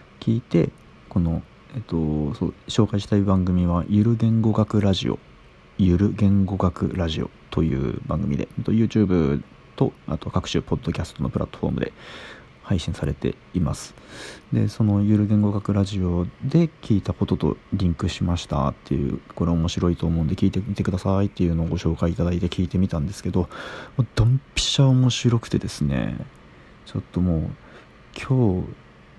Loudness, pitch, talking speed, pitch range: -23 LUFS, 95 Hz, 350 characters per minute, 85-105 Hz